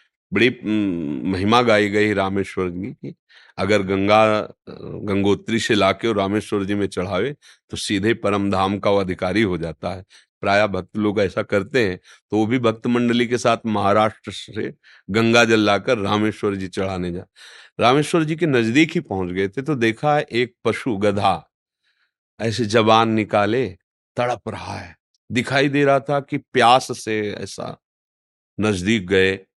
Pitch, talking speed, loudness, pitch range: 105 Hz, 160 wpm, -20 LUFS, 100-115 Hz